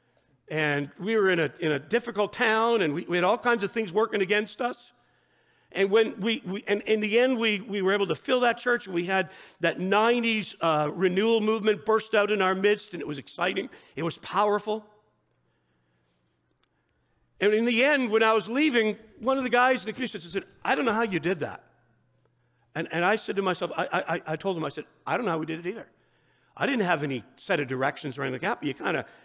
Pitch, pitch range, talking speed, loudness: 205 Hz, 170-225 Hz, 235 wpm, -26 LUFS